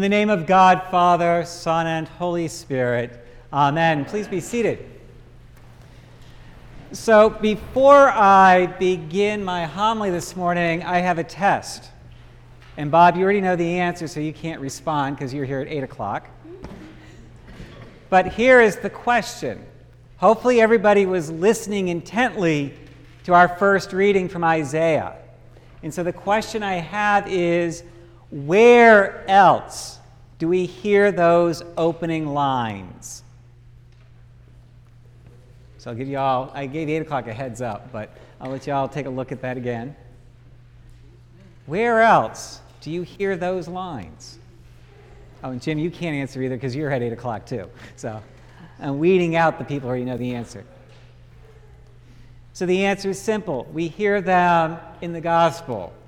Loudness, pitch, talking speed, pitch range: -19 LUFS, 160 Hz, 150 wpm, 125-180 Hz